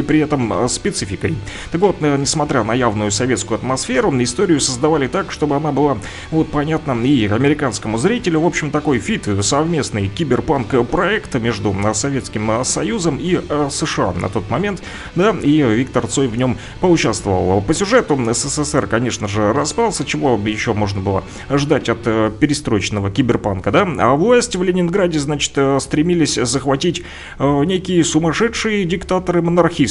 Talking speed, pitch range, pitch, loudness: 140 wpm, 110-160 Hz, 140 Hz, -17 LUFS